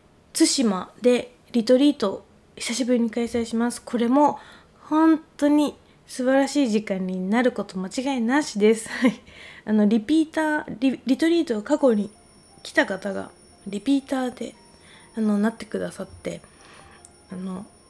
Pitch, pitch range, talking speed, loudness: 245 Hz, 220-280 Hz, 285 characters per minute, -23 LUFS